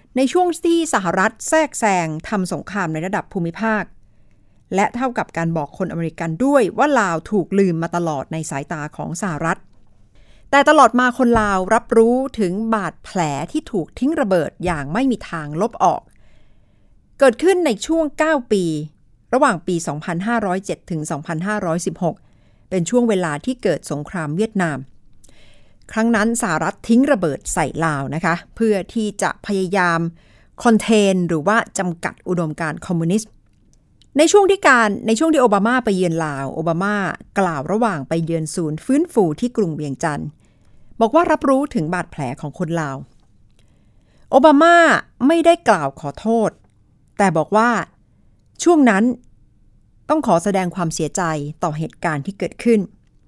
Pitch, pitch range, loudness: 190 Hz, 160-235 Hz, -18 LUFS